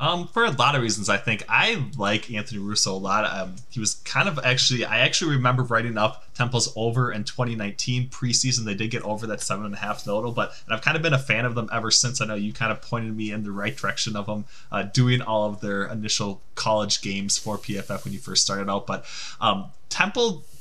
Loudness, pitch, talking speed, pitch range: -24 LUFS, 110 Hz, 240 wpm, 105-125 Hz